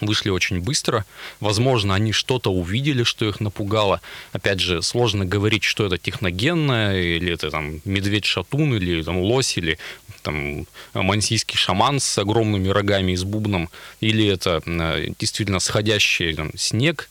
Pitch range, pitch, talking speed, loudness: 90-110 Hz, 105 Hz, 135 wpm, -21 LUFS